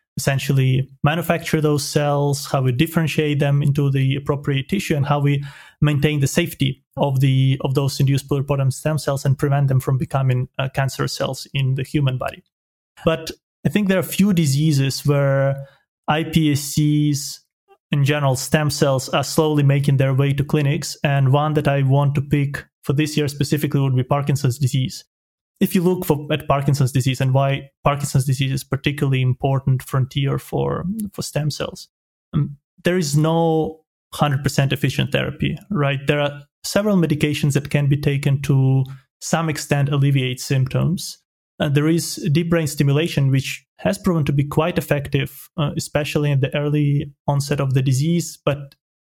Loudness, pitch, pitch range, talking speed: -20 LUFS, 145 Hz, 135-155 Hz, 165 wpm